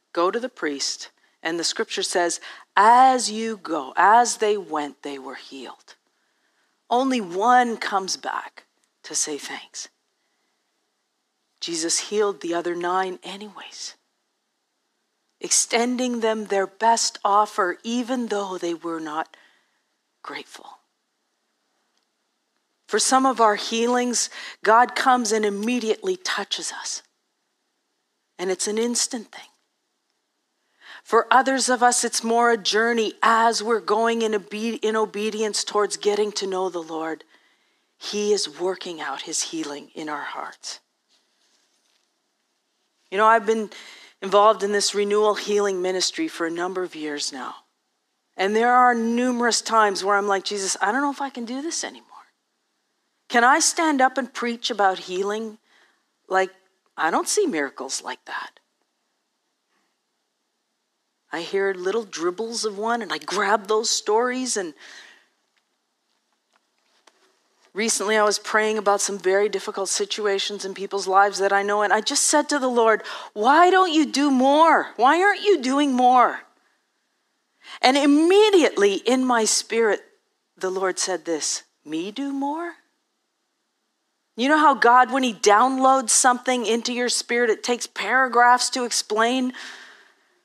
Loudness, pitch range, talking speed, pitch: -21 LUFS, 200-260 Hz, 140 wpm, 225 Hz